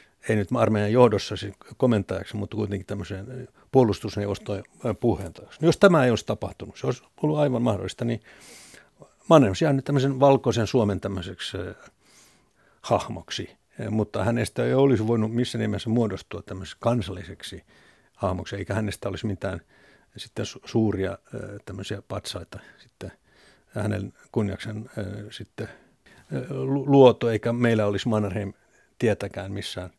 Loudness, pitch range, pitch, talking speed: -25 LUFS, 100-120 Hz, 105 Hz, 120 wpm